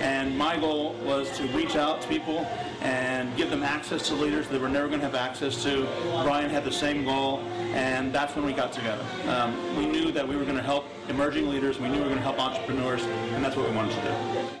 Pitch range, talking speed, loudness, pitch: 130-145 Hz, 250 wpm, -28 LUFS, 135 Hz